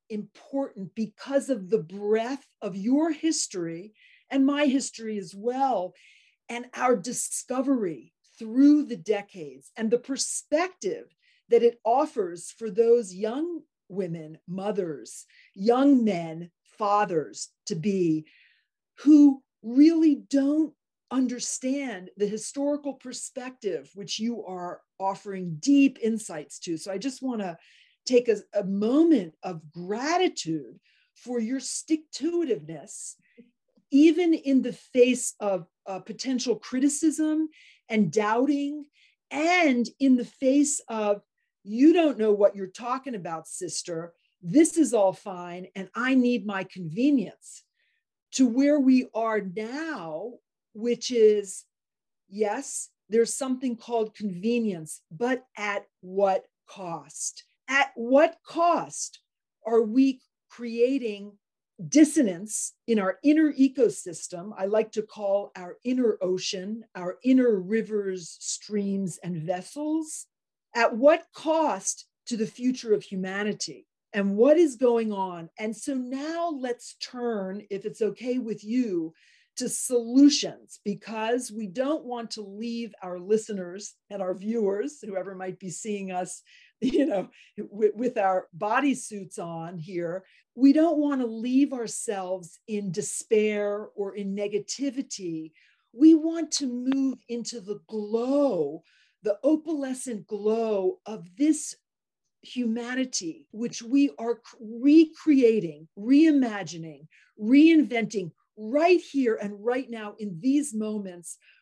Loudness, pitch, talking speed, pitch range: -26 LUFS, 230 Hz, 120 wpm, 200-275 Hz